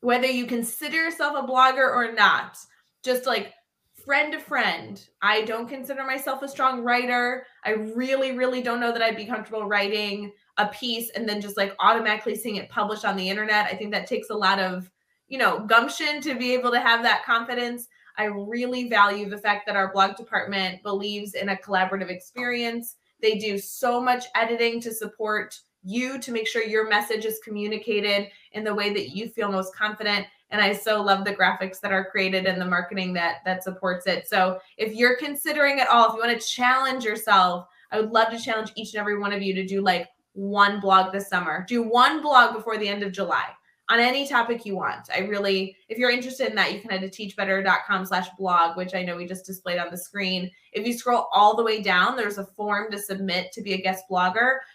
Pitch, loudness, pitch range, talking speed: 215 Hz, -24 LUFS, 195-240 Hz, 215 wpm